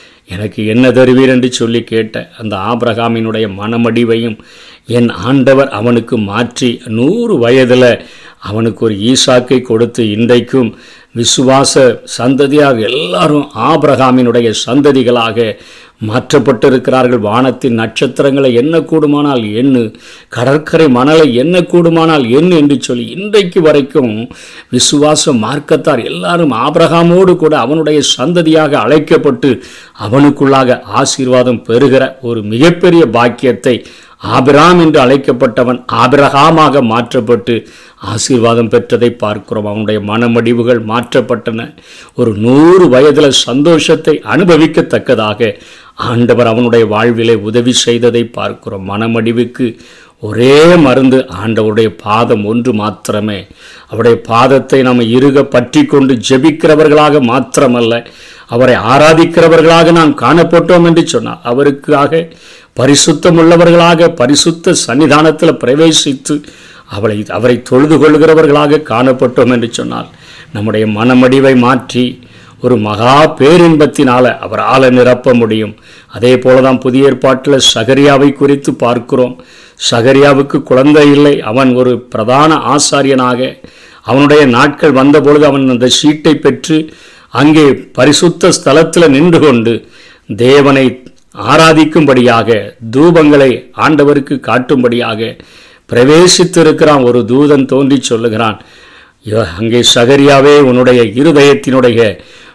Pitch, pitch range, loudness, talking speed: 130 Hz, 120-150 Hz, -8 LUFS, 90 wpm